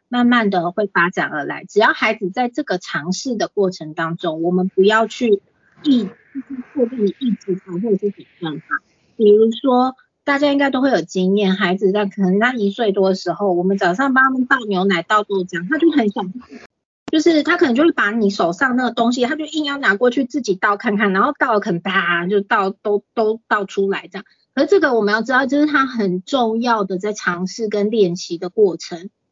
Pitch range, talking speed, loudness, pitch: 190-255 Hz, 305 characters per minute, -17 LUFS, 210 Hz